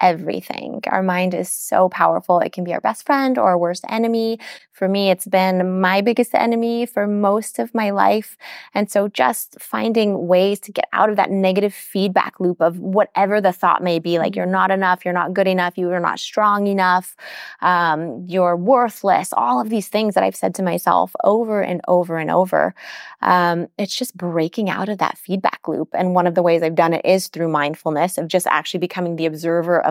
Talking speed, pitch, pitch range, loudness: 210 wpm, 185 Hz, 175-205 Hz, -18 LUFS